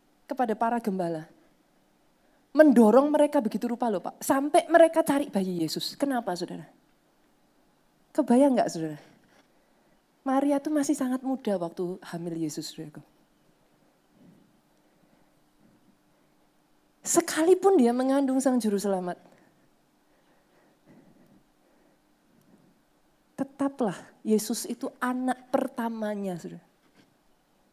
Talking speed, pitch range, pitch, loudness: 85 wpm, 190-280 Hz, 245 Hz, -26 LUFS